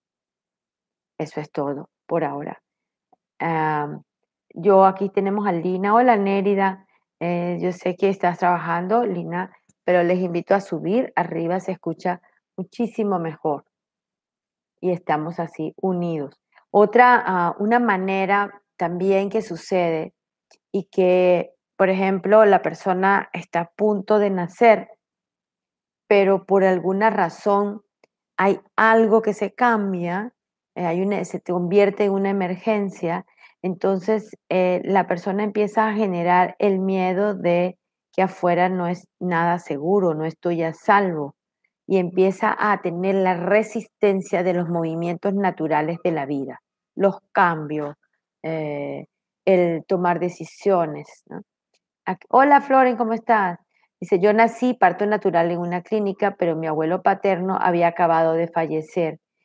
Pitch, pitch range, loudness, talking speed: 185 Hz, 175-205 Hz, -21 LUFS, 130 wpm